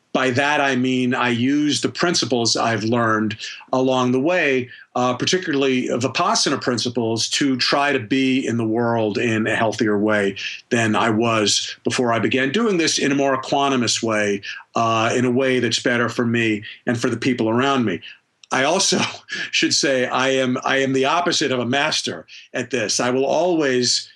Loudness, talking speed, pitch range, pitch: -19 LUFS, 180 wpm, 115-135 Hz, 125 Hz